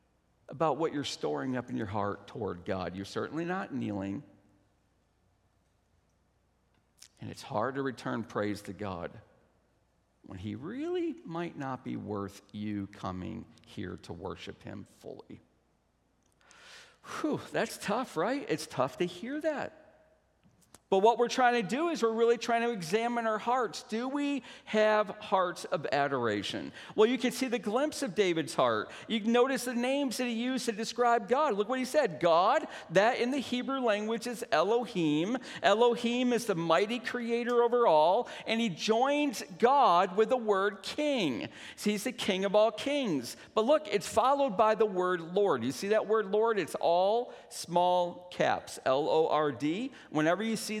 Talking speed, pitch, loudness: 170 wpm, 210 Hz, -30 LUFS